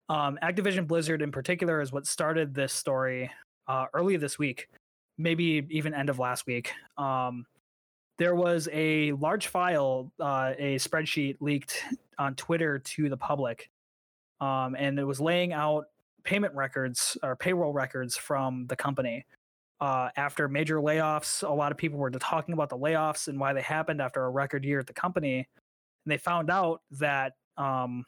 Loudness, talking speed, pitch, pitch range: -30 LUFS, 170 wpm, 145 Hz, 130-160 Hz